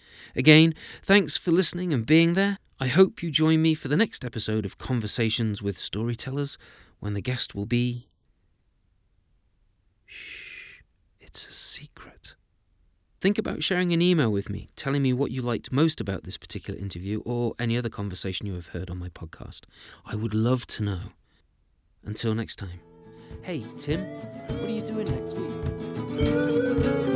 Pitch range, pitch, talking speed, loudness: 100-155 Hz, 115 Hz, 160 wpm, -26 LUFS